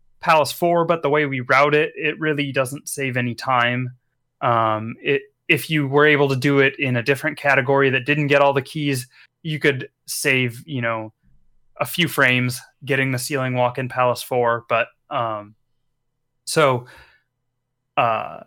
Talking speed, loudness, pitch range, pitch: 170 wpm, -20 LUFS, 125-145 Hz, 135 Hz